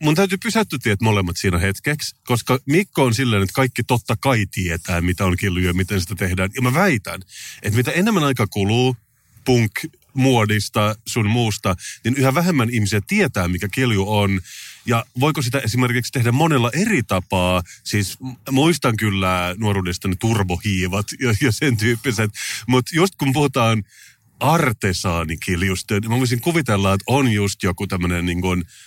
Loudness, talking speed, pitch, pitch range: -19 LUFS, 160 wpm, 115 Hz, 95-130 Hz